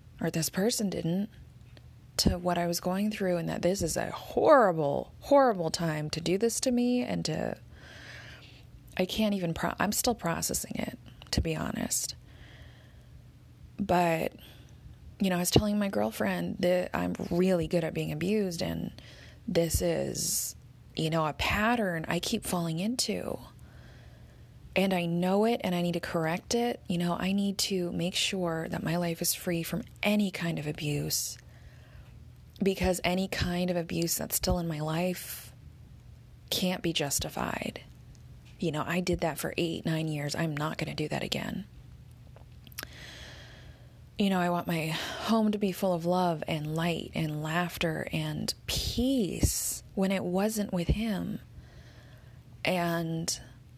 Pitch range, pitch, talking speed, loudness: 165-195 Hz, 175 Hz, 155 wpm, -30 LUFS